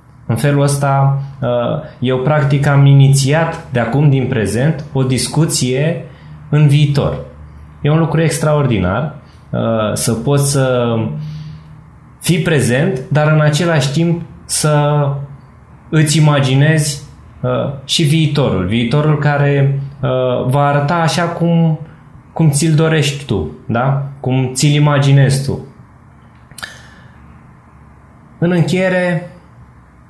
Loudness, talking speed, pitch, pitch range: -14 LUFS, 100 wpm, 145 Hz, 130-155 Hz